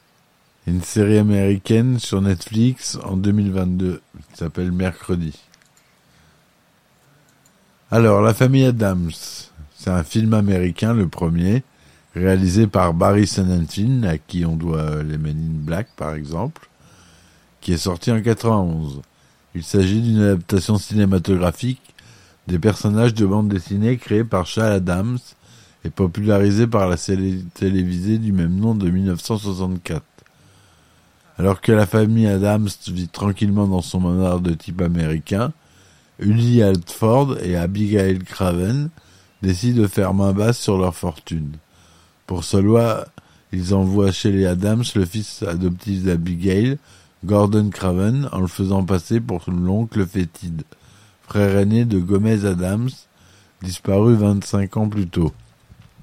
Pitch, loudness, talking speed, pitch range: 95 Hz, -19 LUFS, 130 wpm, 90-105 Hz